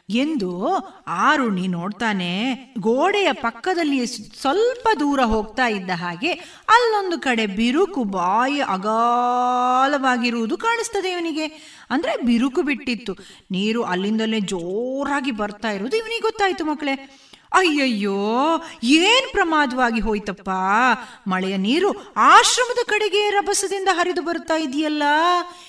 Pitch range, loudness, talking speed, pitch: 220-350 Hz, -20 LUFS, 95 wpm, 270 Hz